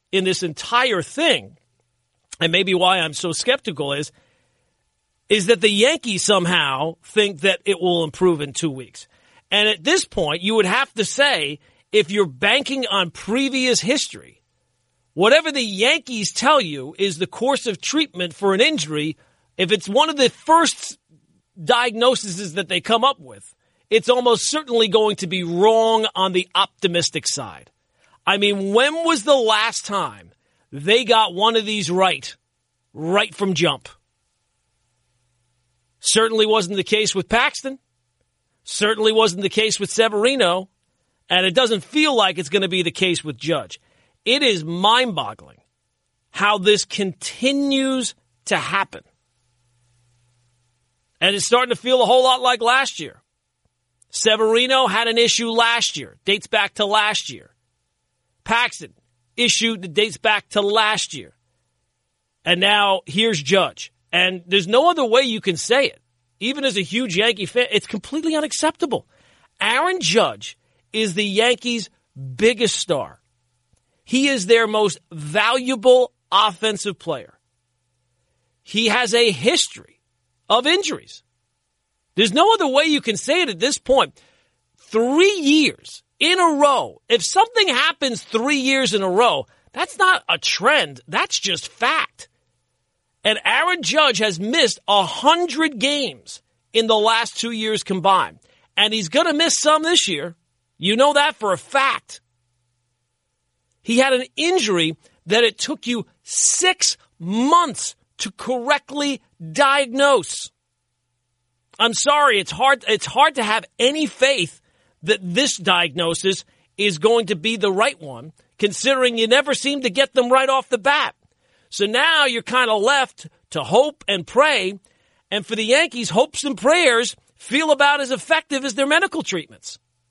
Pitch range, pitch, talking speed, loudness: 165-255 Hz, 210 Hz, 150 wpm, -18 LUFS